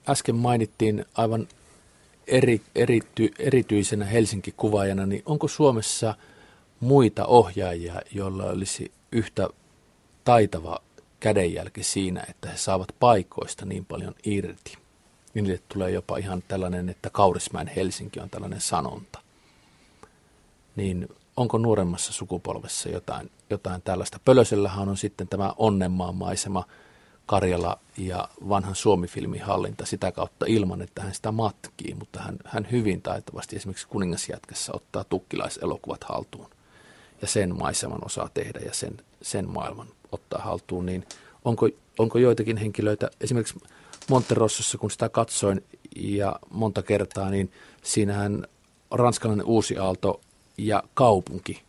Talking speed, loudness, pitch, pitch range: 115 wpm, -26 LUFS, 105 Hz, 95-115 Hz